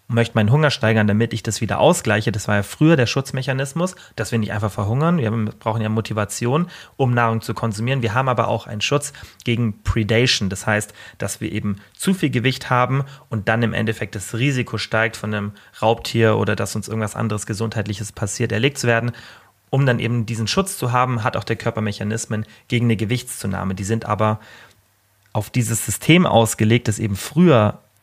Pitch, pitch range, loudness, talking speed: 115 Hz, 105-125 Hz, -20 LUFS, 195 wpm